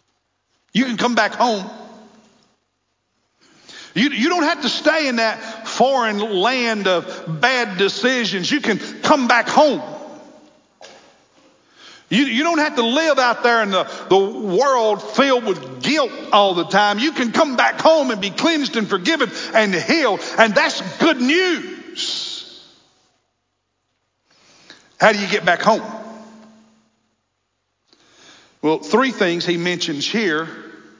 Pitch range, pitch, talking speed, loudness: 200-290 Hz, 230 Hz, 135 wpm, -17 LUFS